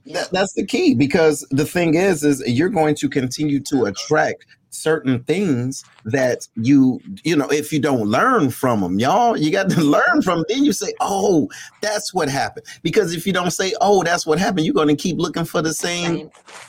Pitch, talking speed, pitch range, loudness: 160 Hz, 205 wpm, 145-190 Hz, -18 LUFS